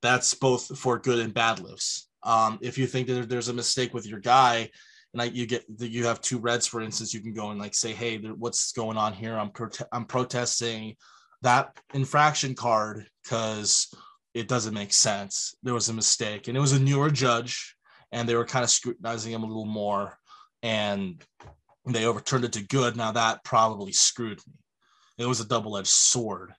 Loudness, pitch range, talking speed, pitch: -26 LUFS, 110-125 Hz, 200 wpm, 115 Hz